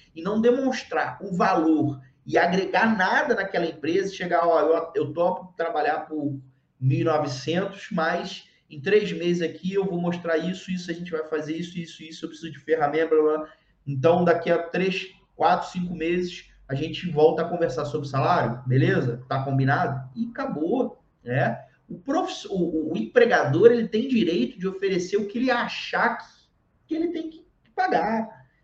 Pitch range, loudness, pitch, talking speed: 155-195 Hz, -24 LUFS, 170 Hz, 175 wpm